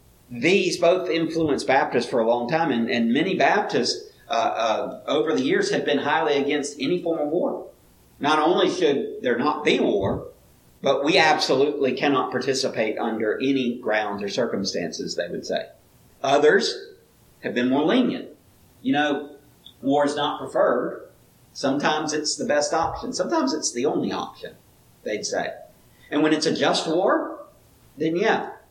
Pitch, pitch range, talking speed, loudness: 155 Hz, 140-180 Hz, 160 wpm, -23 LUFS